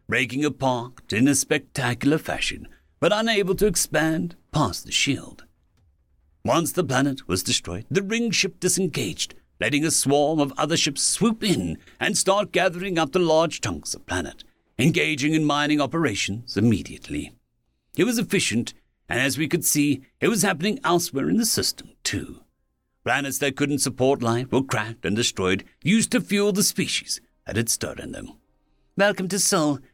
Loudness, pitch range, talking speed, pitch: -23 LUFS, 120-180 Hz, 165 wpm, 145 Hz